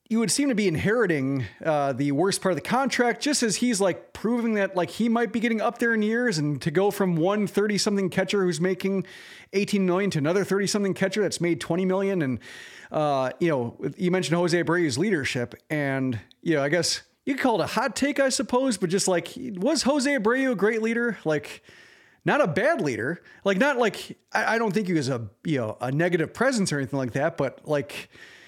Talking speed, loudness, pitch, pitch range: 225 wpm, -25 LUFS, 190 Hz, 155-225 Hz